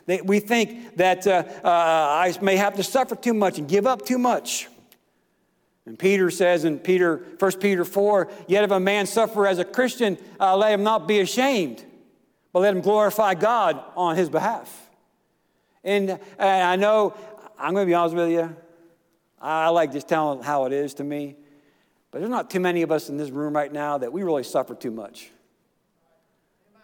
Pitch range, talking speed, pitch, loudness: 170-205 Hz, 190 wpm, 185 Hz, -22 LUFS